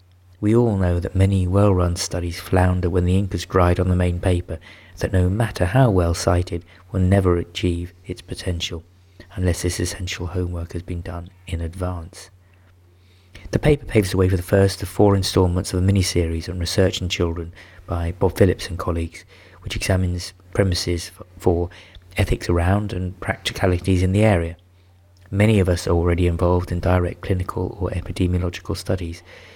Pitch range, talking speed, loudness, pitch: 90-95 Hz, 170 wpm, -21 LUFS, 90 Hz